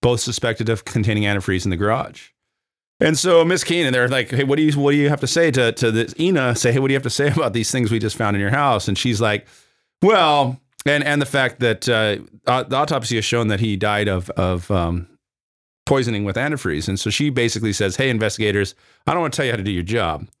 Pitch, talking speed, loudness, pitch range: 120 Hz, 255 wpm, -19 LUFS, 105-140 Hz